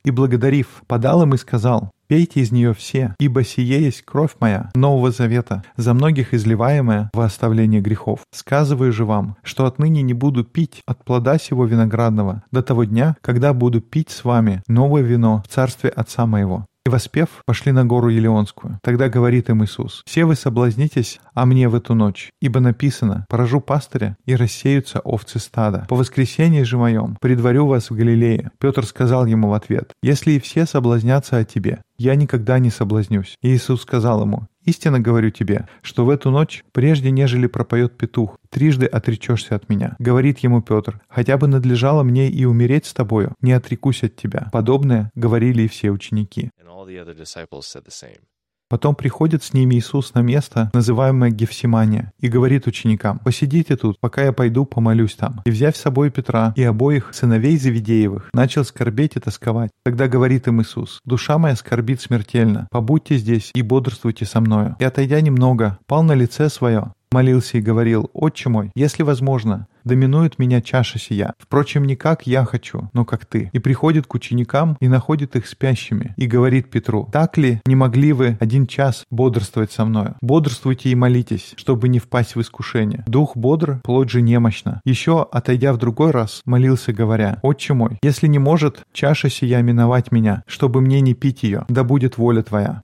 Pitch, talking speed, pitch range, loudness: 125 Hz, 175 wpm, 115-135 Hz, -17 LUFS